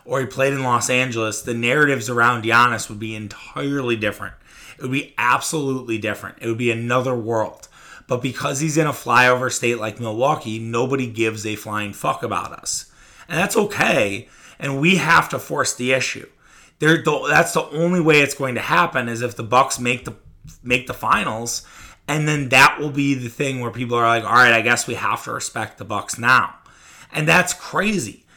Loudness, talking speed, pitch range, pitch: -19 LUFS, 195 wpm, 115-140 Hz, 125 Hz